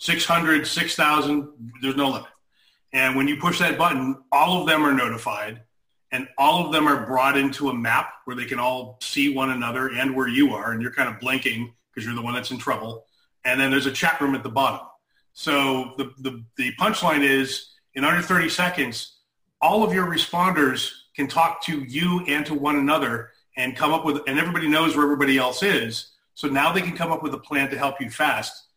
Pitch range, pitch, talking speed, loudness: 130-155 Hz, 140 Hz, 215 wpm, -22 LUFS